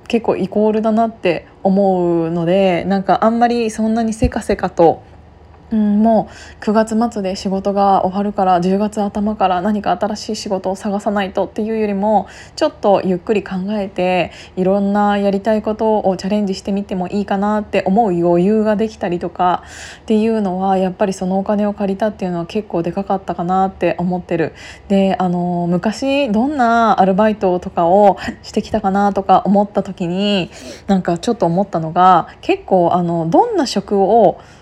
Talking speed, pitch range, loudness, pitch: 355 characters per minute, 185-215 Hz, -16 LUFS, 200 Hz